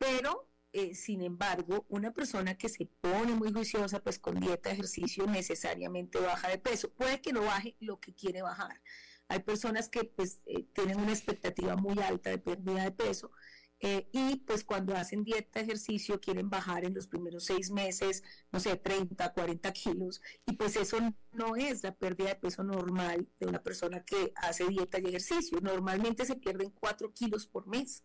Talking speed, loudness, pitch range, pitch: 185 wpm, -36 LUFS, 185-220 Hz, 195 Hz